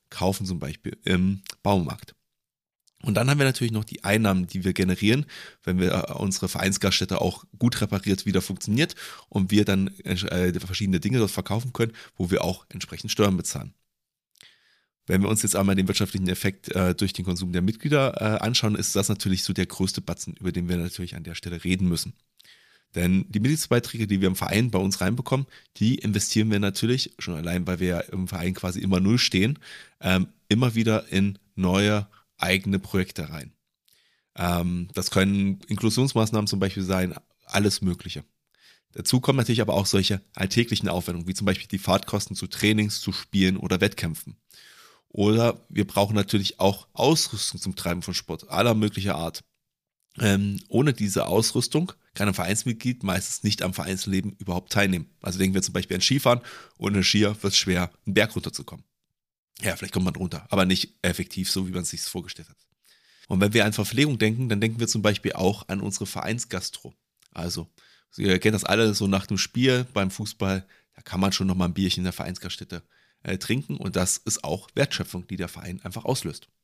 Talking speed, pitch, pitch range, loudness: 185 wpm, 95 Hz, 90-110 Hz, -25 LUFS